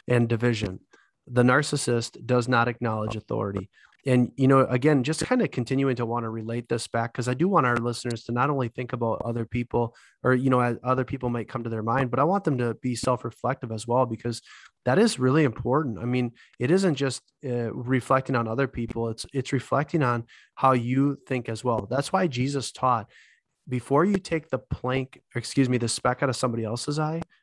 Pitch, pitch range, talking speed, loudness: 125 Hz, 120-135 Hz, 215 wpm, -26 LUFS